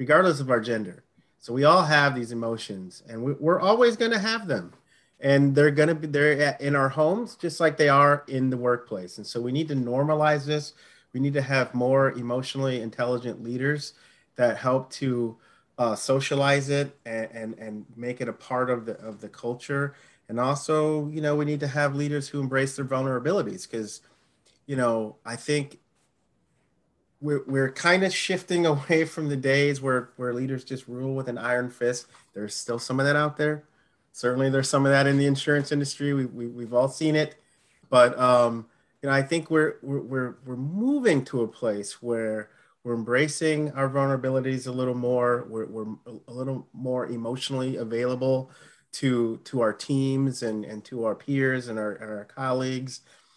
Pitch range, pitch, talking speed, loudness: 120-145 Hz, 130 Hz, 185 wpm, -25 LUFS